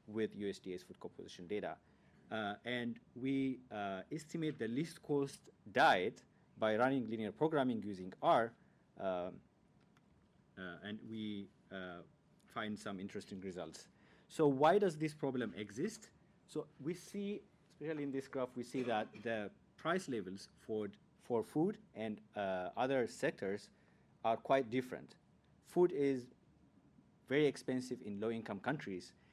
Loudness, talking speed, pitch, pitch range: -40 LUFS, 135 wpm, 125 Hz, 105-150 Hz